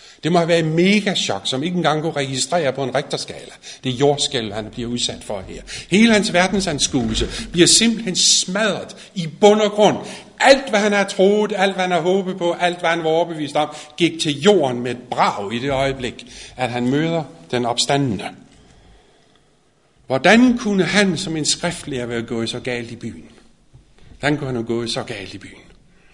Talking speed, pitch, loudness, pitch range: 195 wpm, 160 Hz, -18 LUFS, 125-190 Hz